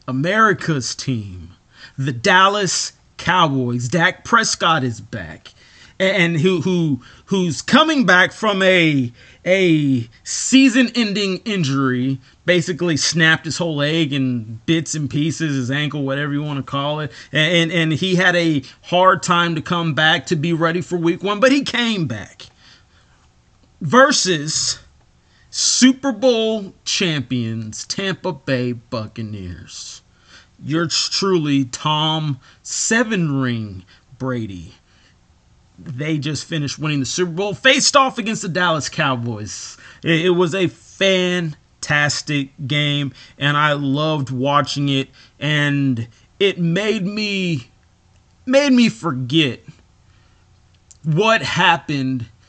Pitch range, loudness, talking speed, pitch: 130-180 Hz, -17 LUFS, 115 wpm, 150 Hz